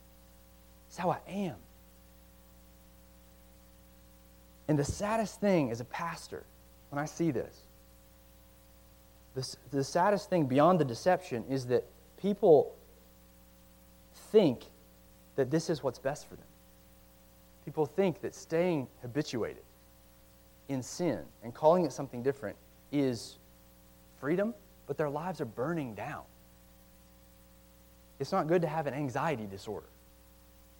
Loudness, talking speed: -32 LUFS, 120 wpm